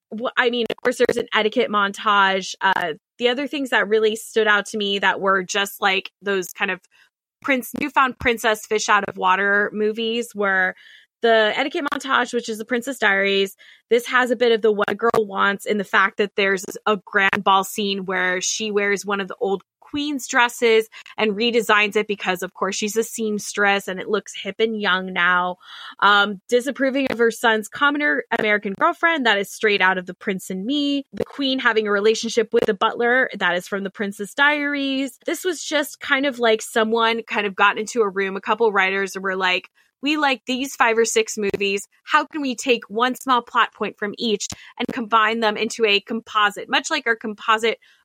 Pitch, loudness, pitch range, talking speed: 220 Hz, -20 LUFS, 200-245 Hz, 200 wpm